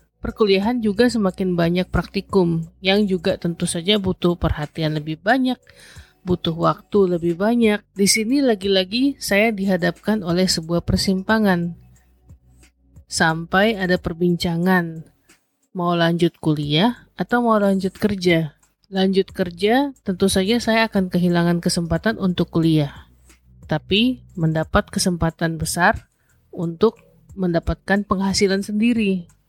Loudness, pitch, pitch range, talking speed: -20 LUFS, 185 Hz, 170-205 Hz, 110 wpm